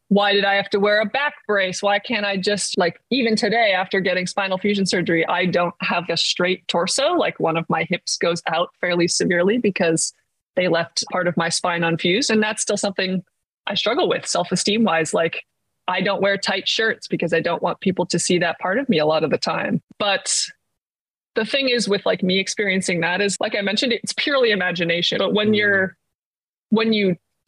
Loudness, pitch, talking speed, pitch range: -20 LUFS, 190 Hz, 210 wpm, 175-210 Hz